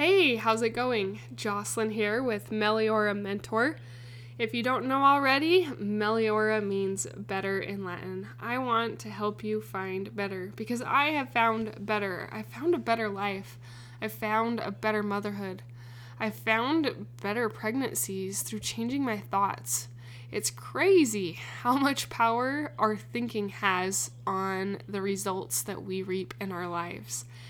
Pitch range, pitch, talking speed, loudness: 185-230 Hz, 205 Hz, 145 wpm, -29 LUFS